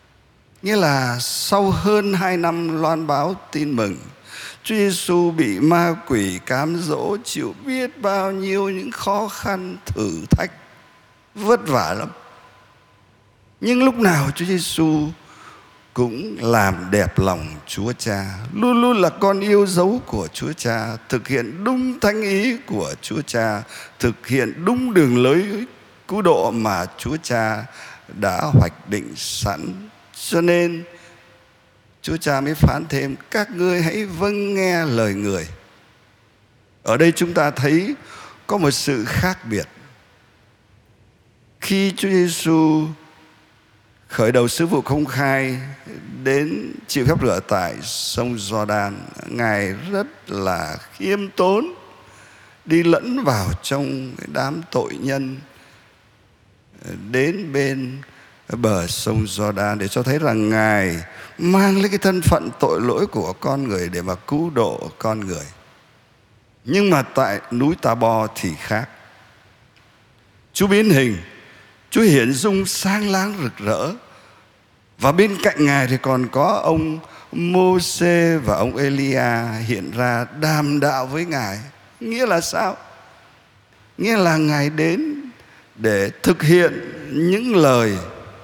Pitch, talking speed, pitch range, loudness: 140 Hz, 135 wpm, 110-180 Hz, -19 LUFS